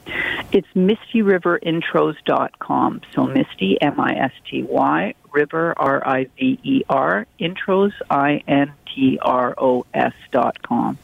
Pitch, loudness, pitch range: 165 Hz, -19 LUFS, 140-205 Hz